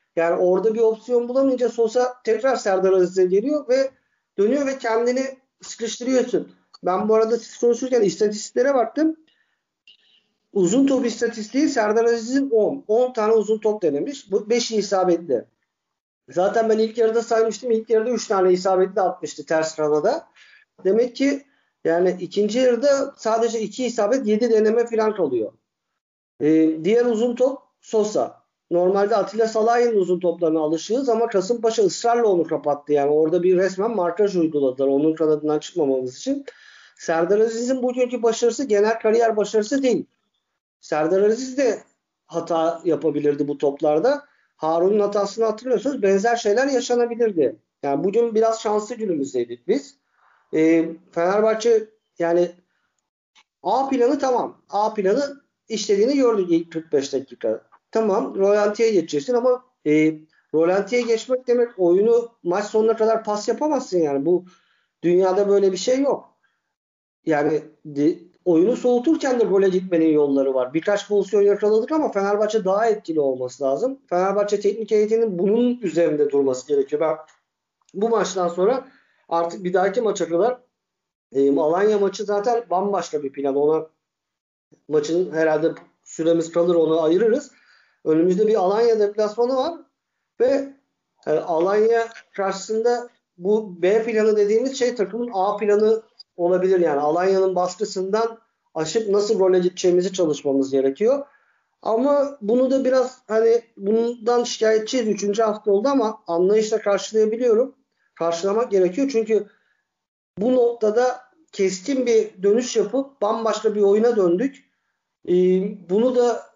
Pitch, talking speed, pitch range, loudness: 215 Hz, 130 wpm, 180-240 Hz, -21 LUFS